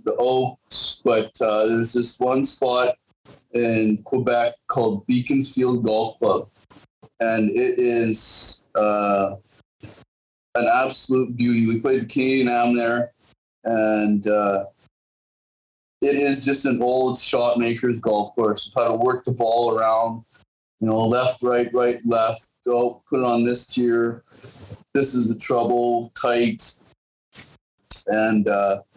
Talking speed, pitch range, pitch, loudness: 135 wpm, 110-125 Hz, 120 Hz, -20 LUFS